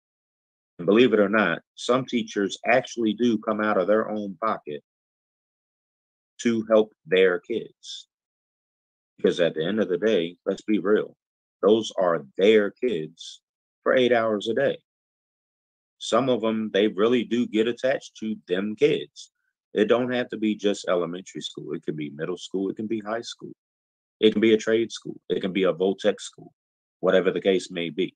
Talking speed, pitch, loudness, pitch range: 180 wpm, 110 Hz, -24 LUFS, 105-125 Hz